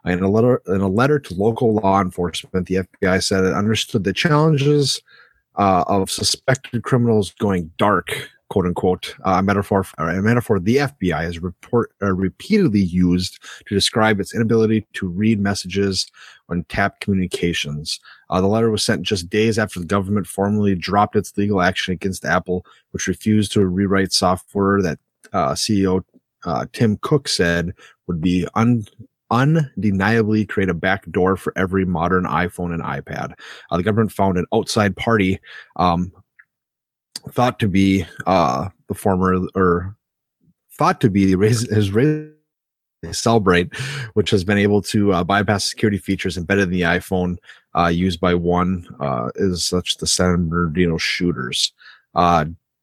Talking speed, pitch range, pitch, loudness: 155 wpm, 90-110 Hz, 95 Hz, -19 LUFS